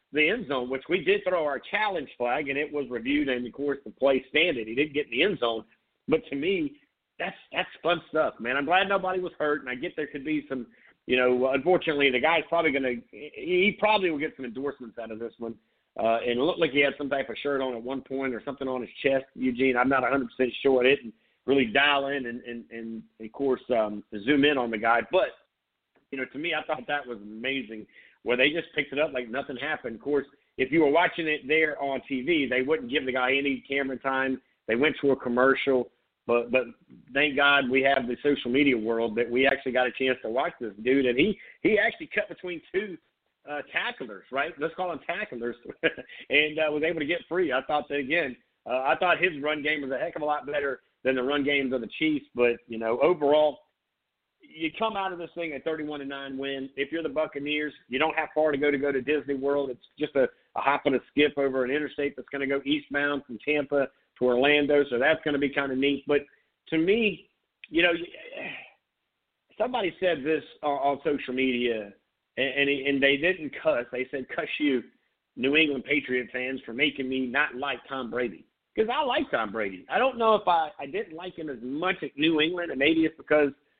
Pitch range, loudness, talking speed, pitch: 130-155 Hz, -27 LUFS, 235 wpm, 140 Hz